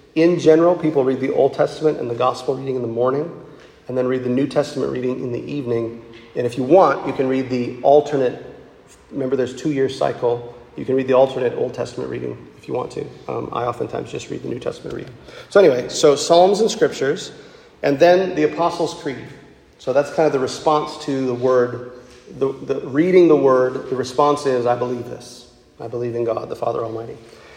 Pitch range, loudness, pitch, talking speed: 125-150 Hz, -19 LUFS, 130 Hz, 210 wpm